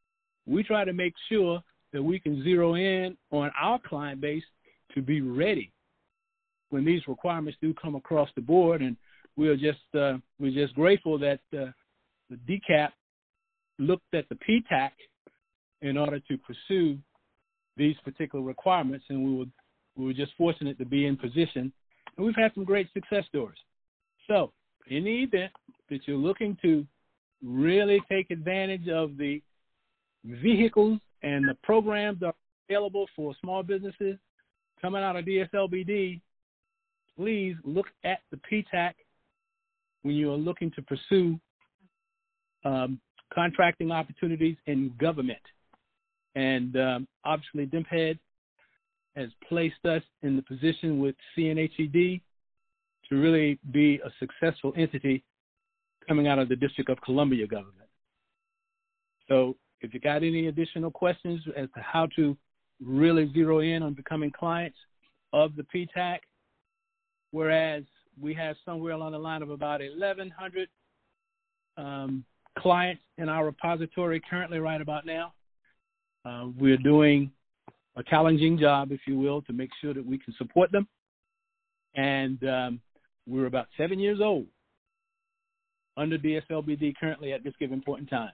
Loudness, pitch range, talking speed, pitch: -28 LUFS, 140-195 Hz, 140 wpm, 160 Hz